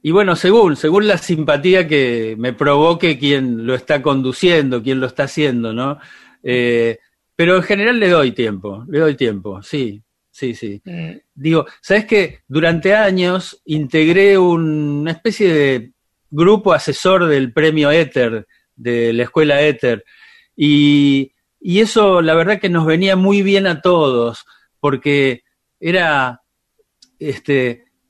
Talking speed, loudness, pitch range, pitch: 135 wpm, -14 LUFS, 130-185 Hz, 150 Hz